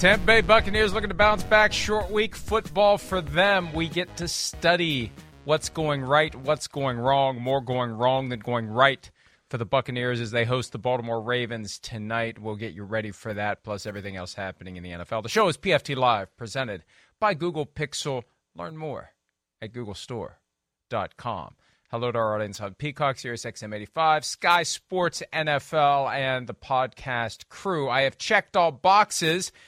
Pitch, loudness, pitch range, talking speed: 130 Hz, -25 LUFS, 115-165 Hz, 170 wpm